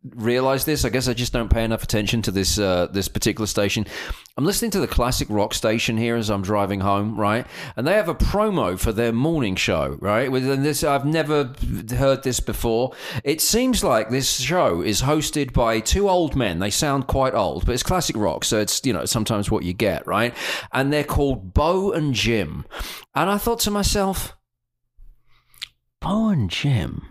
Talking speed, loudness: 195 wpm, -21 LUFS